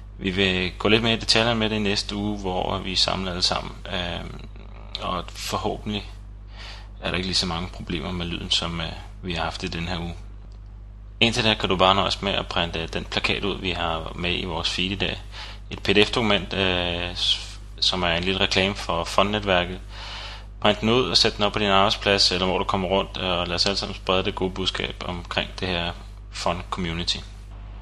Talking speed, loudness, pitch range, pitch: 205 wpm, -23 LUFS, 90-100 Hz, 100 Hz